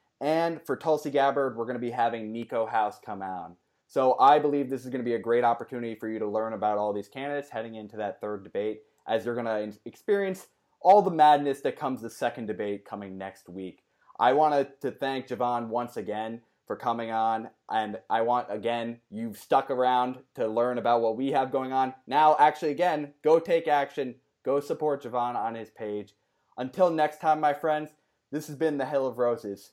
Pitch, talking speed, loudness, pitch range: 125 Hz, 205 wpm, -27 LUFS, 110-145 Hz